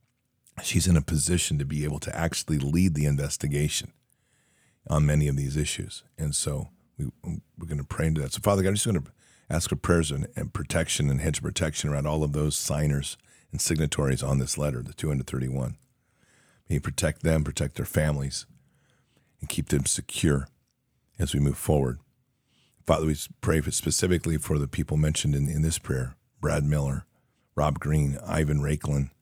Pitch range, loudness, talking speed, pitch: 70-85 Hz, -27 LUFS, 185 wpm, 75 Hz